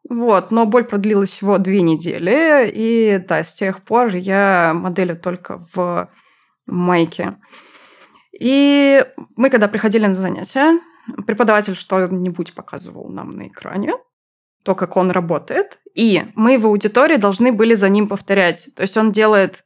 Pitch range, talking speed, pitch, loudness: 185-240 Hz, 140 wpm, 205 Hz, -15 LUFS